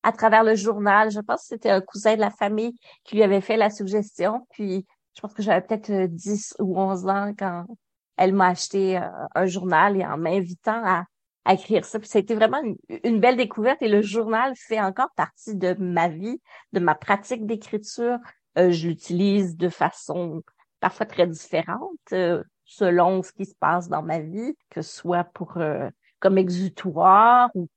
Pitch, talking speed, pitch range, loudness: 200 Hz, 190 wpm, 180-220 Hz, -23 LUFS